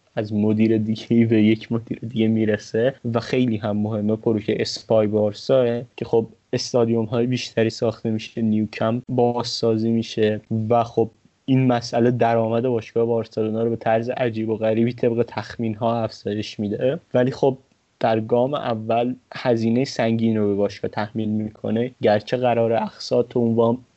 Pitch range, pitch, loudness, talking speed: 110-120 Hz, 115 Hz, -22 LUFS, 150 wpm